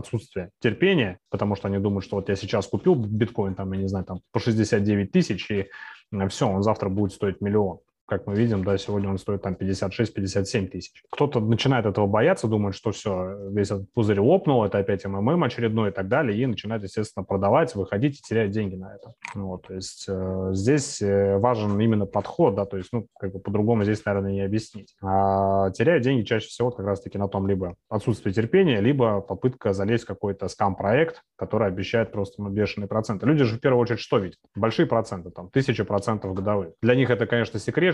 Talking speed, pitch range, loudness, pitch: 200 wpm, 100-115 Hz, -24 LUFS, 105 Hz